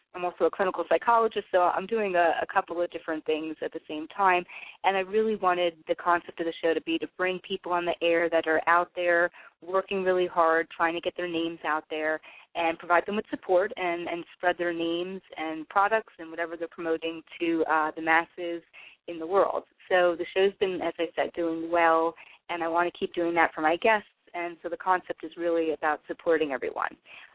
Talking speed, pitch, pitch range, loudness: 220 wpm, 170 Hz, 165-180 Hz, -27 LUFS